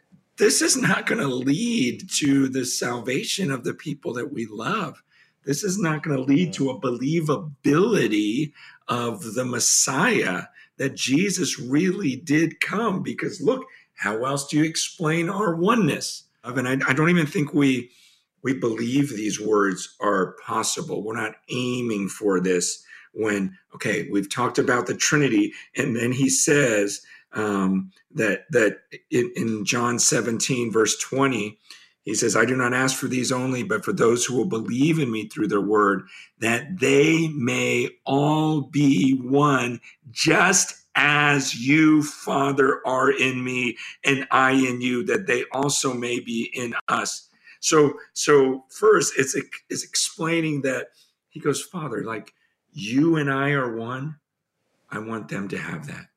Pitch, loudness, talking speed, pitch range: 135 Hz, -22 LUFS, 155 wpm, 120-155 Hz